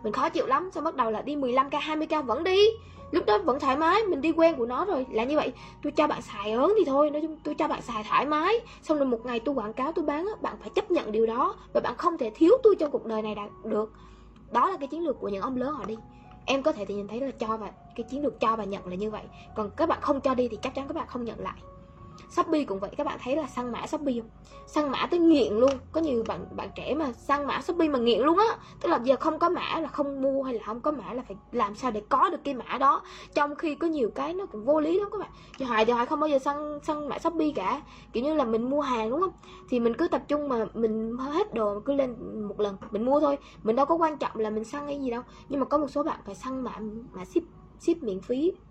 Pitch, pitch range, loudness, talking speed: 275 Hz, 230-310 Hz, -28 LUFS, 295 wpm